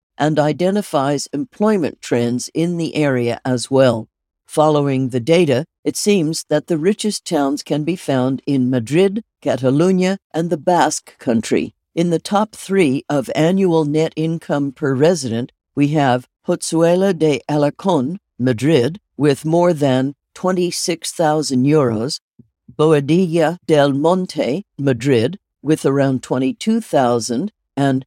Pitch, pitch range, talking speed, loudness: 155 Hz, 135-175 Hz, 125 wpm, -17 LUFS